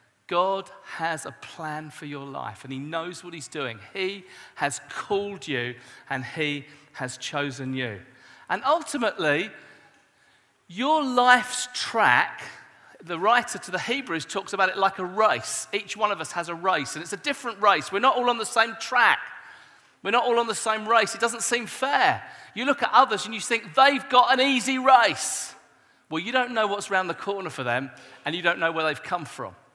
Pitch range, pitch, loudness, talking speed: 155-235 Hz, 195 Hz, -24 LUFS, 200 wpm